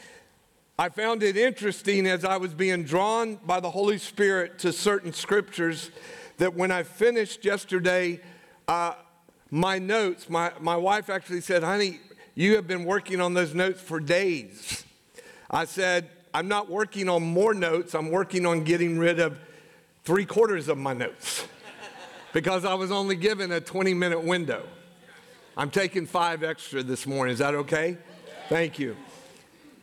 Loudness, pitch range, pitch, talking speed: -26 LUFS, 170-200 Hz, 180 Hz, 155 wpm